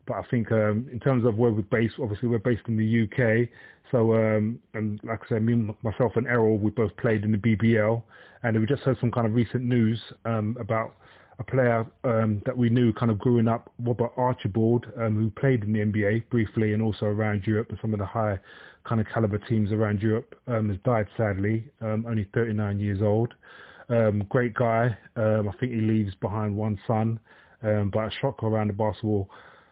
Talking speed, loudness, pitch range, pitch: 210 wpm, -26 LUFS, 110-120 Hz, 110 Hz